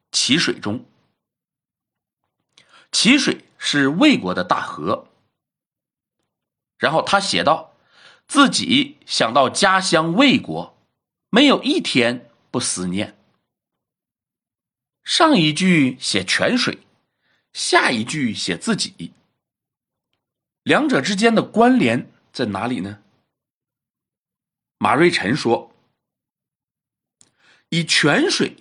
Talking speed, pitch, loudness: 130 characters per minute, 190 Hz, -18 LUFS